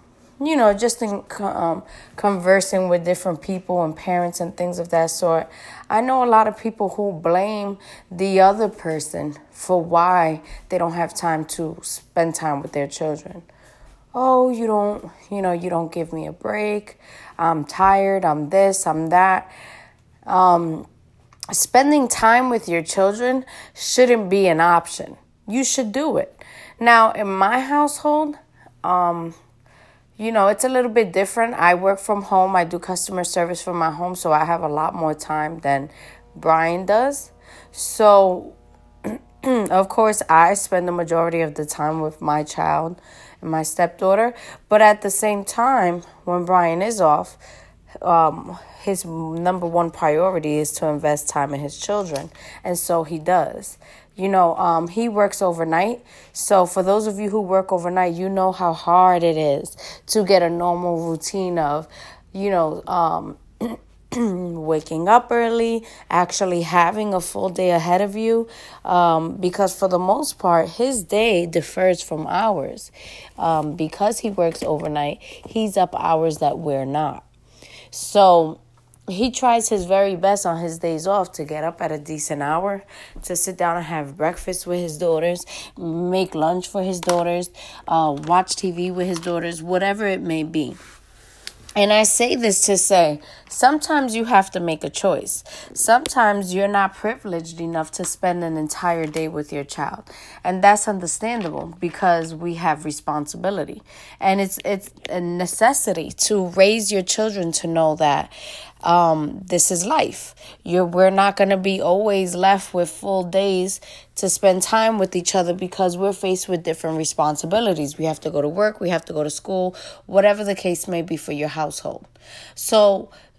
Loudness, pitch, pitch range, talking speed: -19 LUFS, 180 Hz, 165-200 Hz, 165 wpm